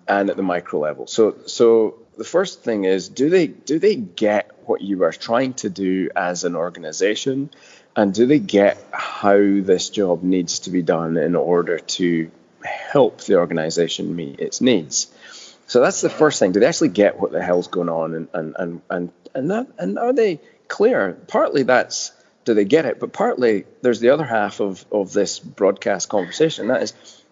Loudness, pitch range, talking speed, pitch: -19 LUFS, 85-115 Hz, 195 wpm, 95 Hz